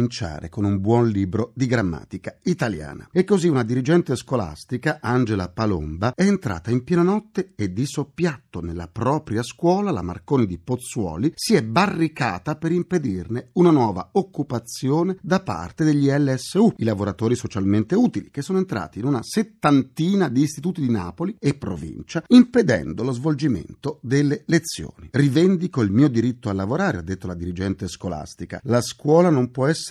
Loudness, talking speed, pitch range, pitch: -22 LUFS, 155 wpm, 110-165 Hz, 130 Hz